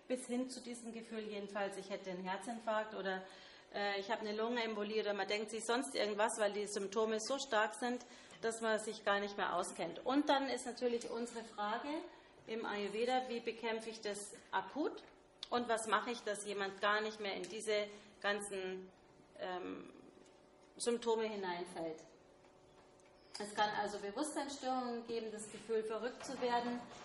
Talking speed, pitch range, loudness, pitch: 160 wpm, 205-235 Hz, -40 LUFS, 220 Hz